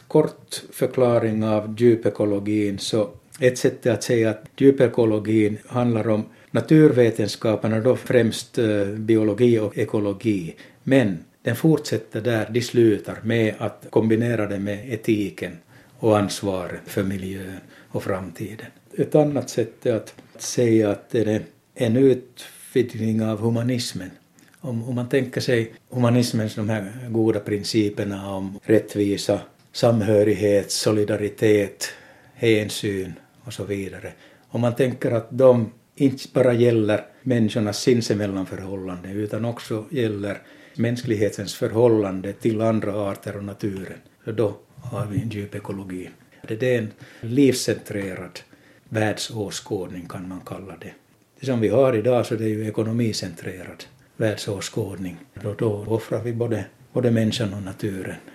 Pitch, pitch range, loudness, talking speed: 110 Hz, 100-120 Hz, -22 LUFS, 125 wpm